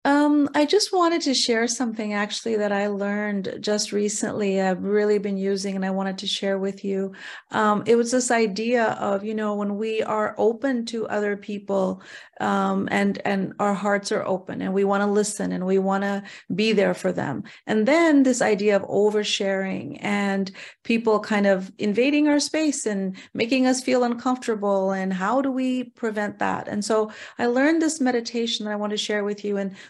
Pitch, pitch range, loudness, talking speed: 210 Hz, 200-240 Hz, -23 LUFS, 195 wpm